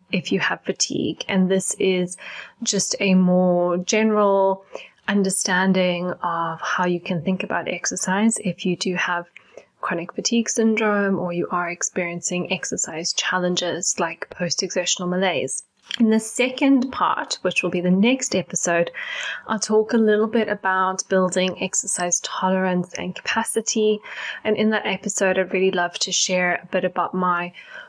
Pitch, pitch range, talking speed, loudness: 185 Hz, 180-215 Hz, 150 wpm, -21 LUFS